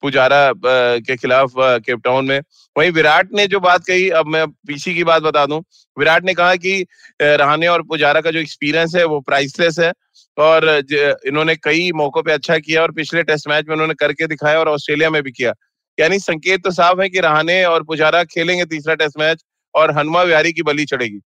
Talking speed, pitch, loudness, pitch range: 200 wpm, 155 Hz, -15 LUFS, 145-170 Hz